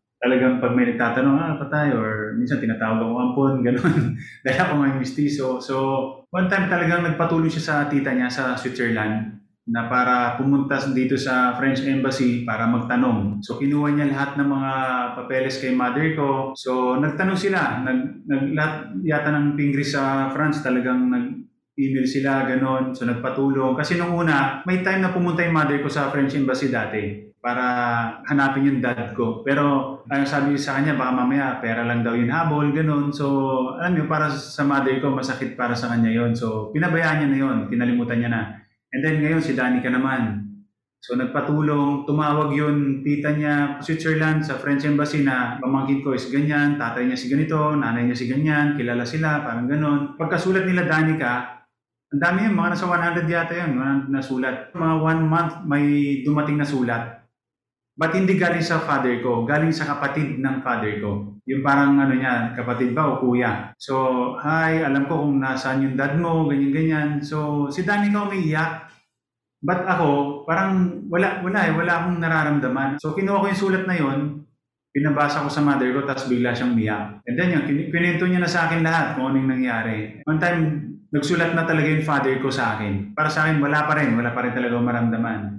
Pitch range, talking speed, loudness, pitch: 125-155 Hz, 185 wpm, -21 LUFS, 140 Hz